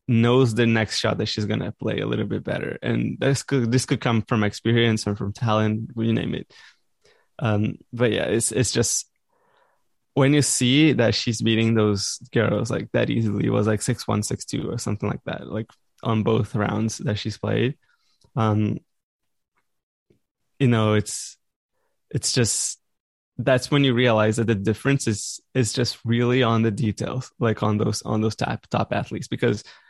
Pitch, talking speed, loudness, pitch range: 115 Hz, 185 wpm, -23 LUFS, 105-125 Hz